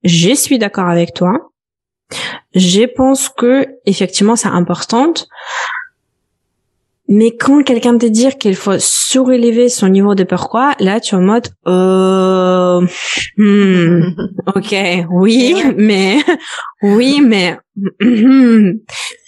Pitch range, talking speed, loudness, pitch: 185-255 Hz, 110 wpm, -11 LUFS, 210 Hz